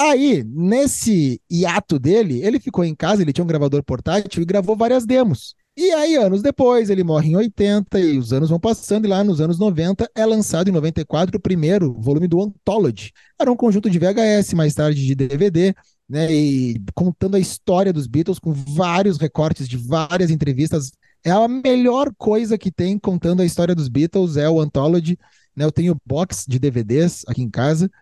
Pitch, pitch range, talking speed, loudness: 180 Hz, 155-205 Hz, 190 wpm, -18 LUFS